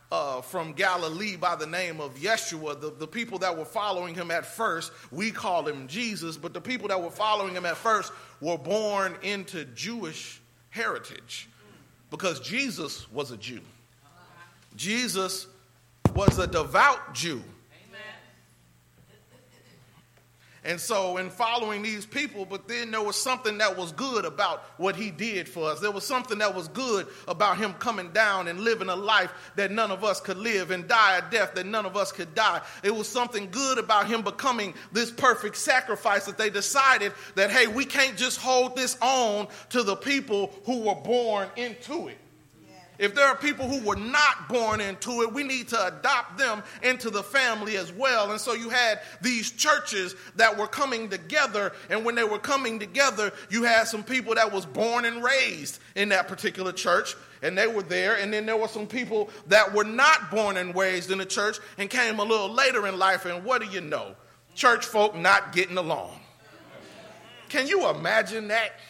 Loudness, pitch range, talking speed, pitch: -26 LUFS, 185-235 Hz, 185 wpm, 210 Hz